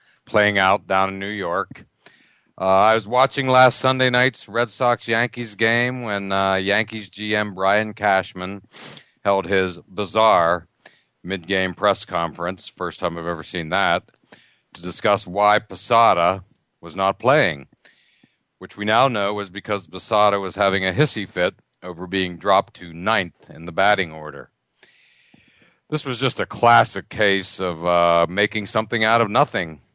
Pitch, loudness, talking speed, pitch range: 100 Hz, -20 LUFS, 155 wpm, 95-110 Hz